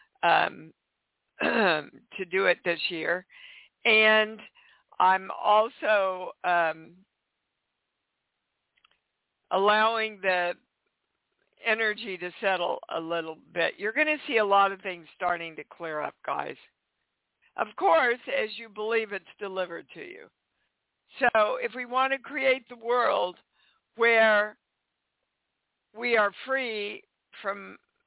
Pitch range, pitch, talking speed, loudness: 180-230 Hz, 210 Hz, 115 wpm, -26 LUFS